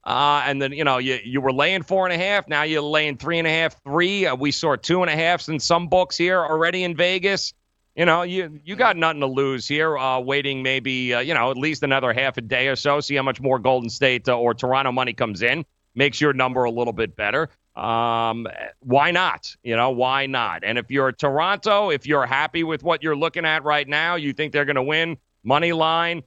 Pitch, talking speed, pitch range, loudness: 145 Hz, 245 wpm, 130-165 Hz, -21 LUFS